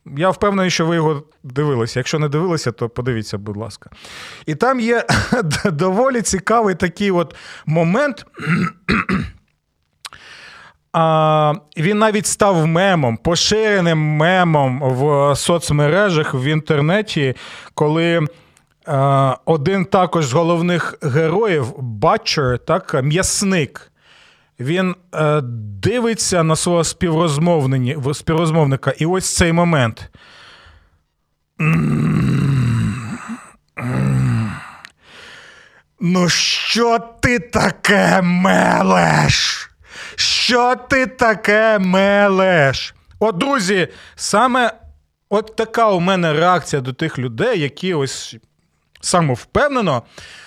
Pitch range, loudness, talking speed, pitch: 135-190 Hz, -16 LUFS, 85 wpm, 160 Hz